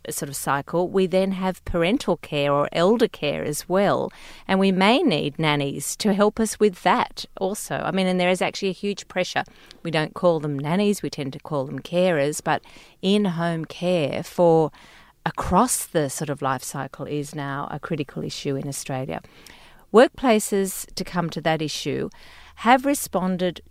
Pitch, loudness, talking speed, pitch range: 175 Hz, -23 LUFS, 175 wpm, 145-195 Hz